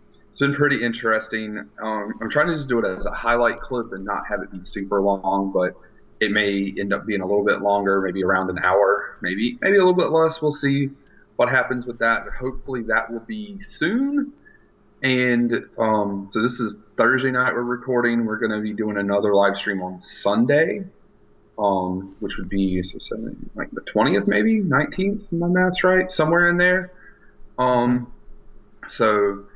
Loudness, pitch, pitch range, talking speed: -21 LUFS, 115 Hz, 100-140 Hz, 185 wpm